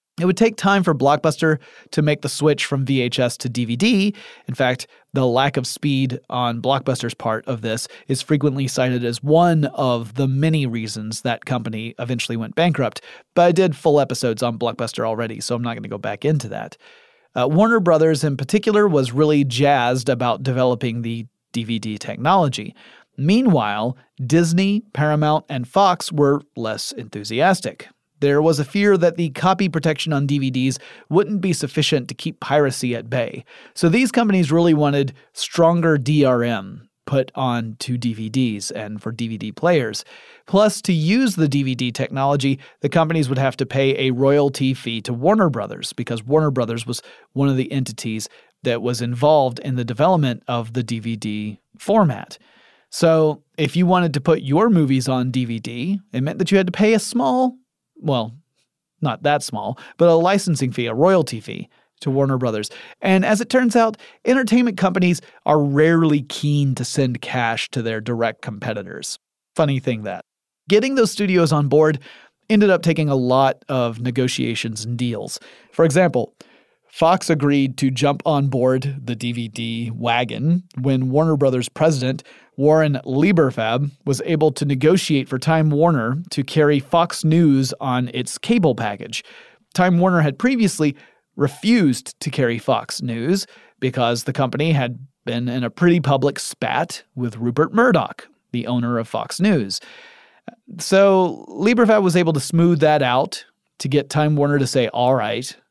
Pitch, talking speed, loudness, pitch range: 140 Hz, 165 wpm, -19 LUFS, 125-165 Hz